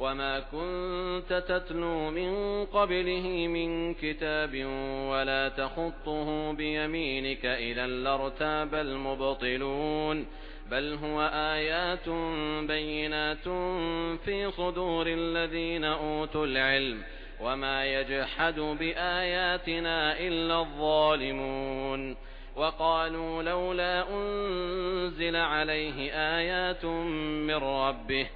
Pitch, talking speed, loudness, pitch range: 155 Hz, 70 wpm, -30 LUFS, 135-170 Hz